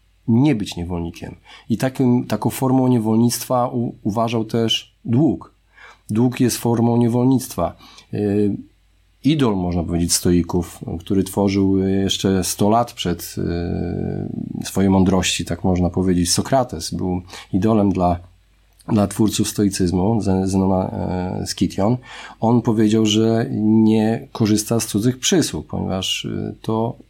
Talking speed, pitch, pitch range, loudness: 115 wpm, 105 Hz, 90-115 Hz, -19 LUFS